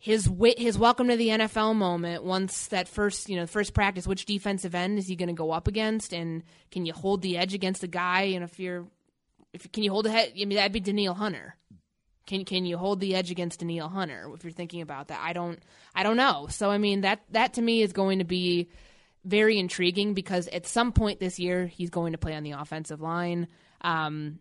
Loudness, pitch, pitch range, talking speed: -28 LUFS, 185 Hz, 175-205 Hz, 230 wpm